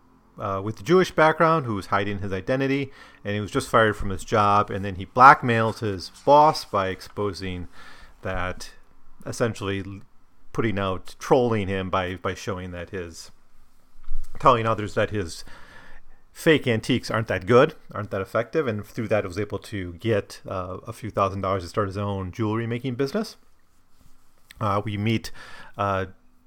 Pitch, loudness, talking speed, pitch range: 100 Hz, -23 LUFS, 165 wpm, 95-115 Hz